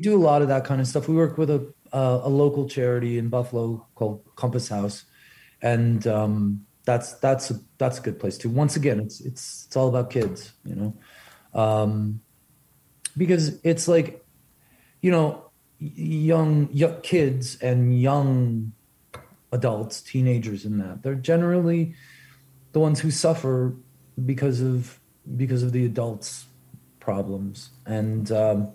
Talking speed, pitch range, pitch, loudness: 150 wpm, 115-145 Hz, 130 Hz, -24 LUFS